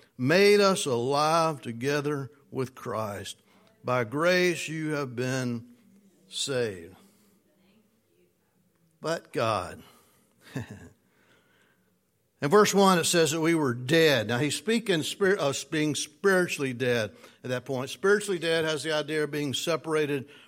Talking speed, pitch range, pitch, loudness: 125 wpm, 135-175 Hz, 150 Hz, -26 LUFS